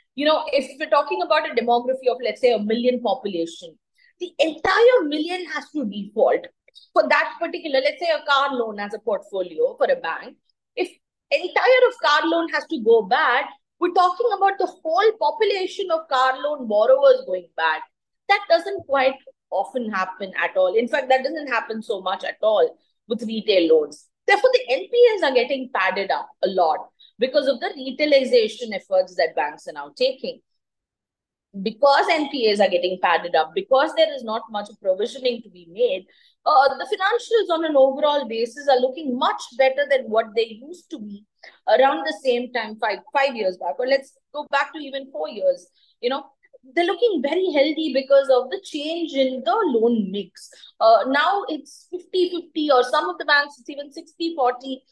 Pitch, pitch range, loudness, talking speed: 280 Hz, 235-335 Hz, -21 LUFS, 180 wpm